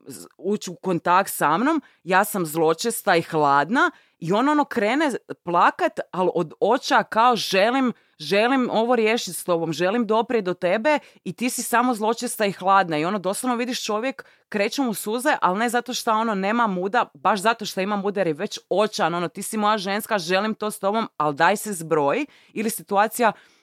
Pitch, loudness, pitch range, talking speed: 210 Hz, -22 LUFS, 185-235 Hz, 190 wpm